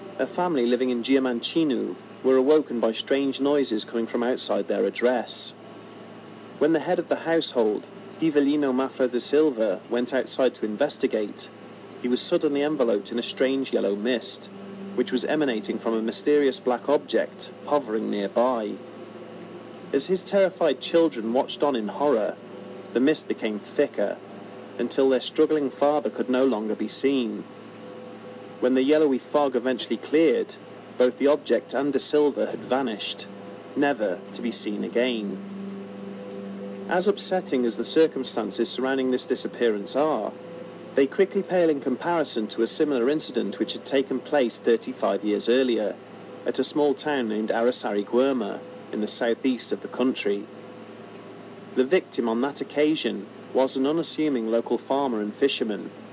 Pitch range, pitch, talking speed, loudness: 115-145 Hz, 130 Hz, 150 wpm, -23 LUFS